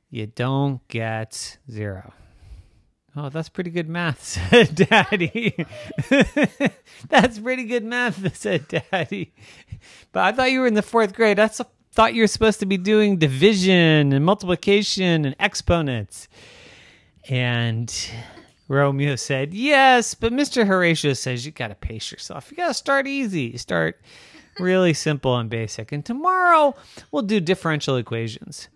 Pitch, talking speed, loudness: 170 Hz, 140 wpm, -20 LUFS